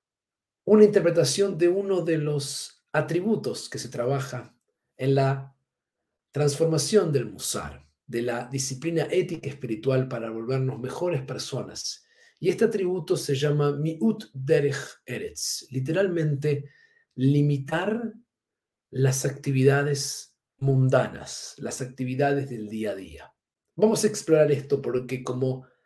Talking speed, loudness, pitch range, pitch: 115 wpm, -26 LUFS, 130-170 Hz, 140 Hz